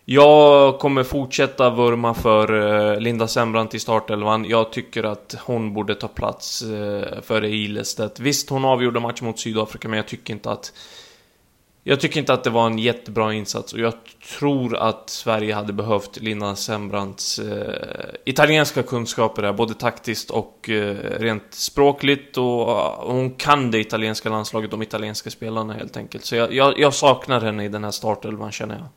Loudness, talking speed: -20 LUFS, 160 wpm